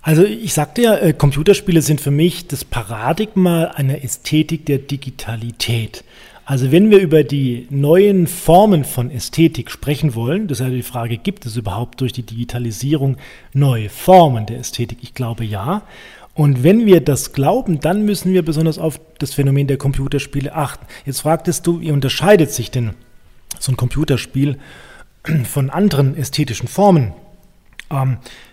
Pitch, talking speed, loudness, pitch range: 140 Hz, 155 wpm, -16 LUFS, 125-165 Hz